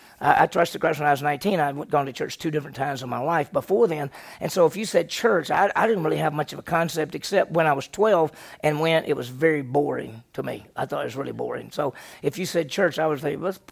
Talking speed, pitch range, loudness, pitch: 265 wpm, 145-170 Hz, -24 LUFS, 155 Hz